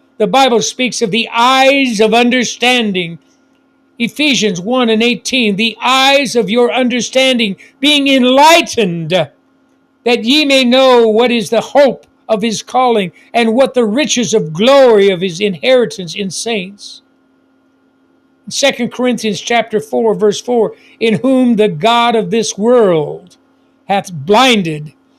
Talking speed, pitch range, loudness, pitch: 135 wpm, 220-270 Hz, -11 LUFS, 240 Hz